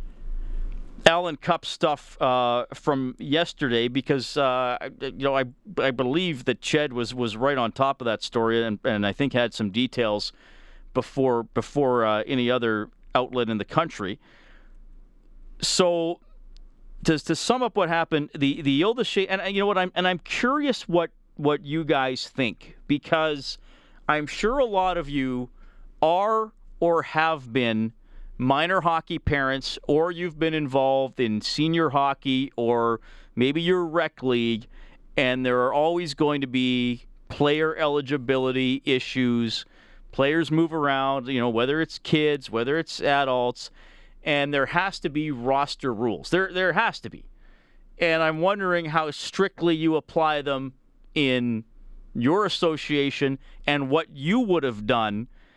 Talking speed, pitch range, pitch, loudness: 150 wpm, 125-165 Hz, 140 Hz, -24 LUFS